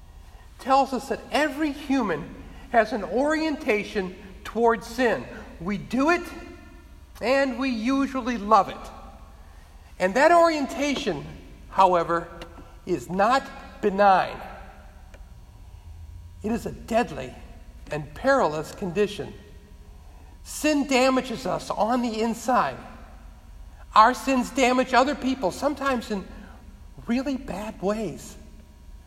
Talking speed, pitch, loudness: 100 wpm, 220 Hz, -24 LUFS